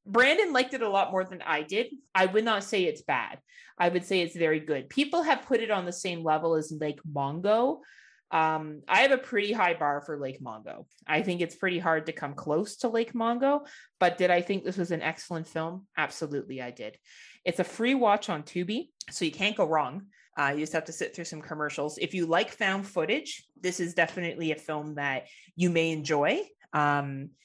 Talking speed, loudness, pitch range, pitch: 220 wpm, -28 LUFS, 155-210 Hz, 175 Hz